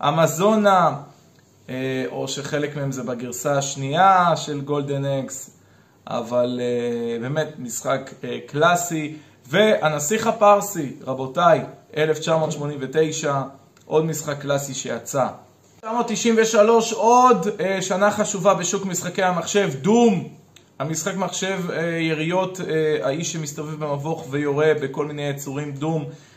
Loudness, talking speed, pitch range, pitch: -21 LUFS, 95 wpm, 140-190 Hz, 155 Hz